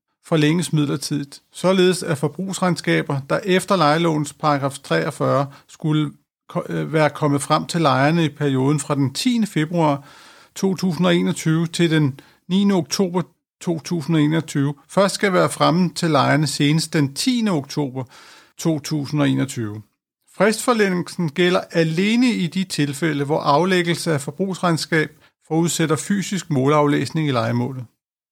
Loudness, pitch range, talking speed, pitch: -20 LUFS, 145-180 Hz, 115 wpm, 155 Hz